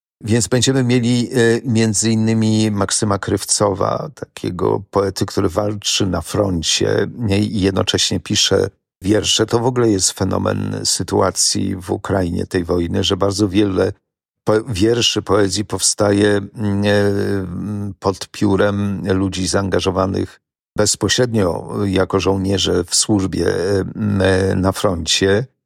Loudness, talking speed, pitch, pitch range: -17 LUFS, 105 wpm, 100 Hz, 95-110 Hz